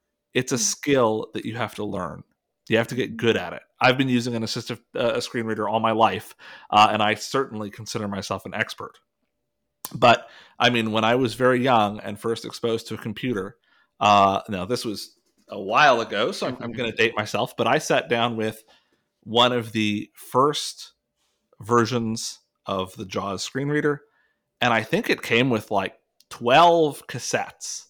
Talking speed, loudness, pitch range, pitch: 185 wpm, -23 LUFS, 105-125 Hz, 115 Hz